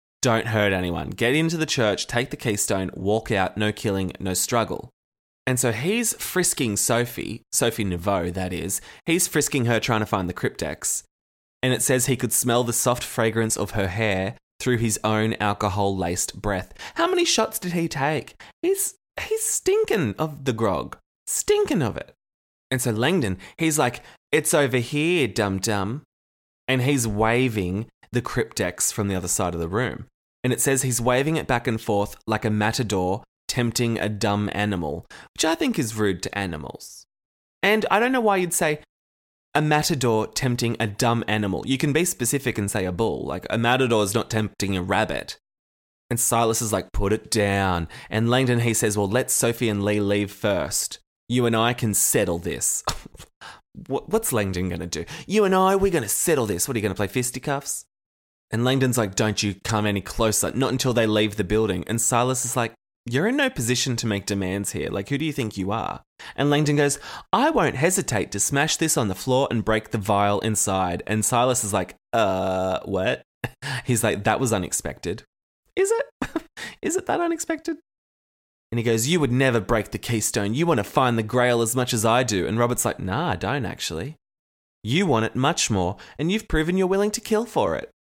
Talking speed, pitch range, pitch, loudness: 200 wpm, 100-135 Hz, 115 Hz, -23 LUFS